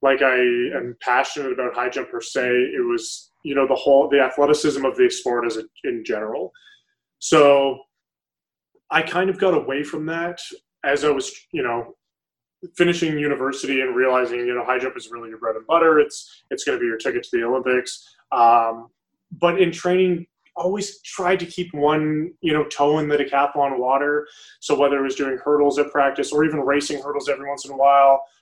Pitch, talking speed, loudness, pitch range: 145 Hz, 195 wpm, -20 LUFS, 135-180 Hz